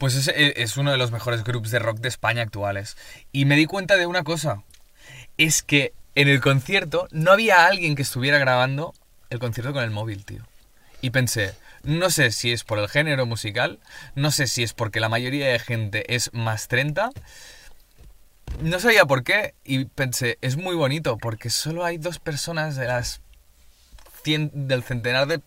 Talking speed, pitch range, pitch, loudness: 185 wpm, 115-150 Hz, 130 Hz, -22 LUFS